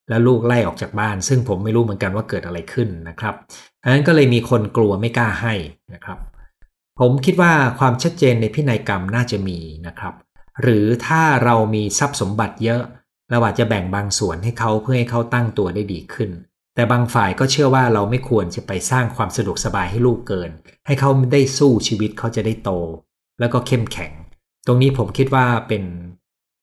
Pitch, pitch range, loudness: 115 Hz, 100-125 Hz, -18 LUFS